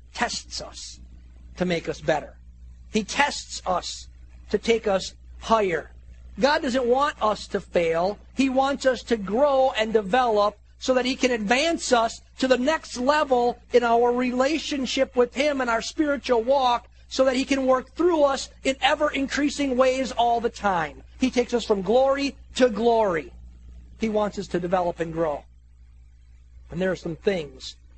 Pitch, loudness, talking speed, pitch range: 235 Hz, -23 LUFS, 165 wpm, 165-265 Hz